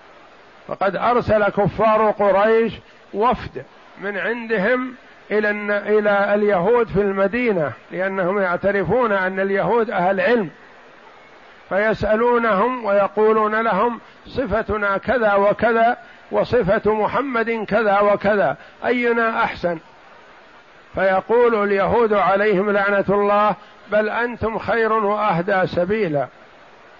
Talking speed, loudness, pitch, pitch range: 85 wpm, -19 LUFS, 210 Hz, 200-225 Hz